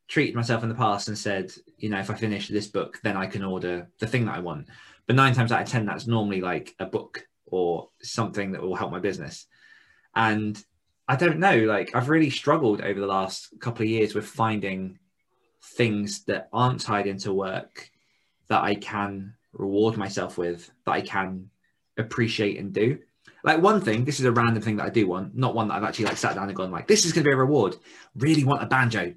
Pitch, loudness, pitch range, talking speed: 110 Hz, -25 LUFS, 95-120 Hz, 225 wpm